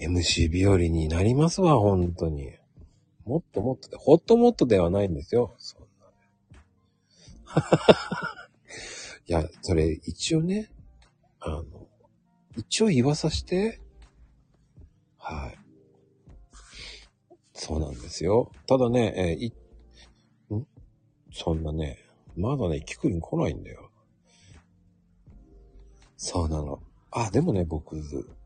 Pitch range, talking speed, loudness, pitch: 80-120 Hz, 200 characters per minute, -26 LUFS, 90 Hz